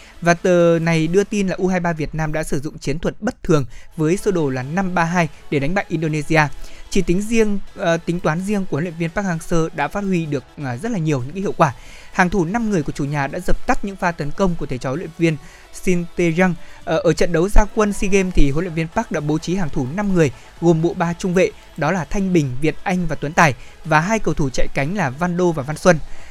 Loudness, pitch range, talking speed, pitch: -20 LUFS, 155-190 Hz, 265 wpm, 170 Hz